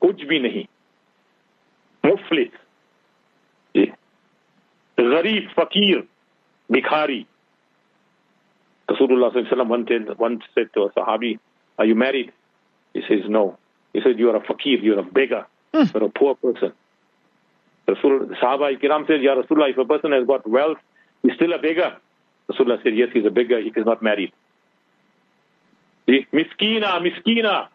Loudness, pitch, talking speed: -20 LUFS, 165 Hz, 135 wpm